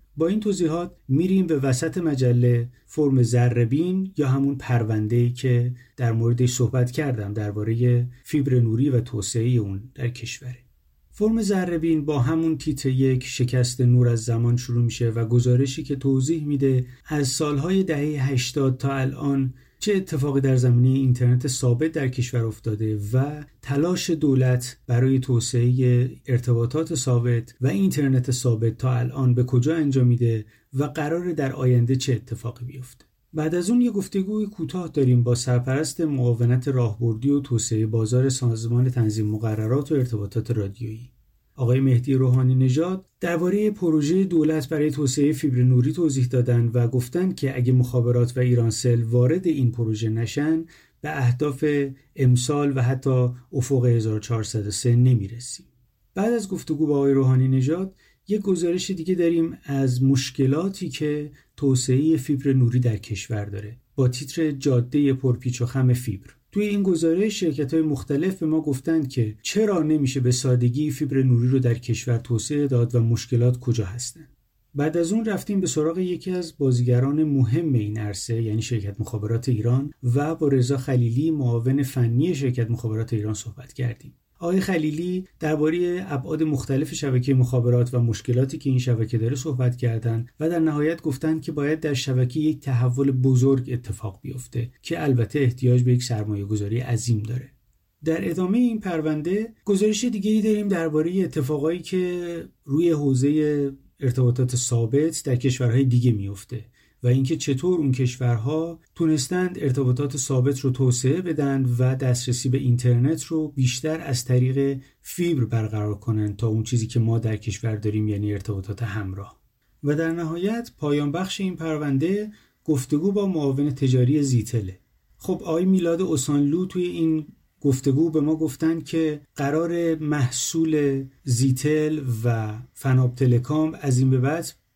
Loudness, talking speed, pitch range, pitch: -23 LUFS, 150 wpm, 120-155 Hz, 130 Hz